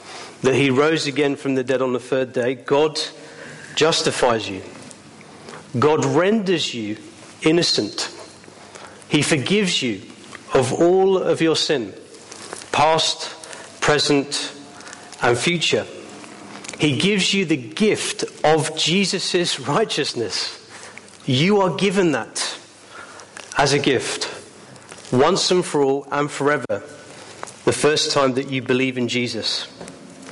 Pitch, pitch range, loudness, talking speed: 150 Hz, 135-180 Hz, -19 LUFS, 115 wpm